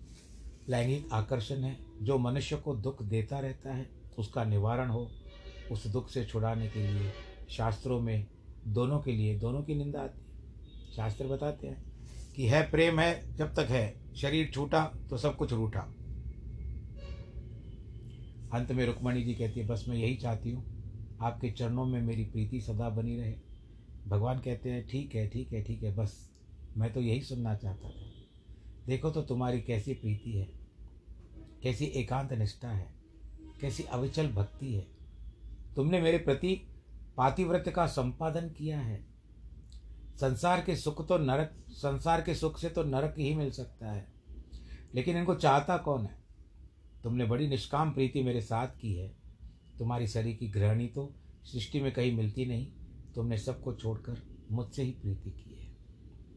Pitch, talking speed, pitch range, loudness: 120 Hz, 160 wpm, 105-135 Hz, -34 LUFS